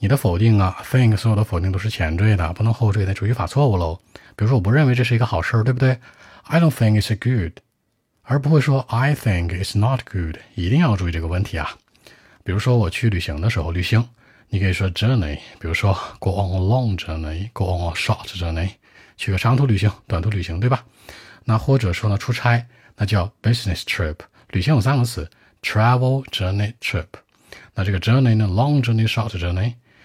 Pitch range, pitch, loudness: 95-120 Hz, 110 Hz, -20 LUFS